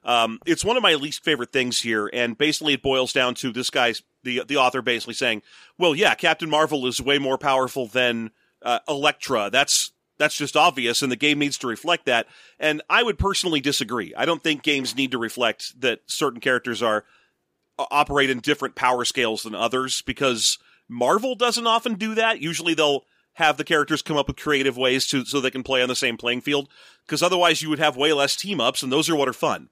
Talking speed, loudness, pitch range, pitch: 220 wpm, -22 LUFS, 125-150 Hz, 140 Hz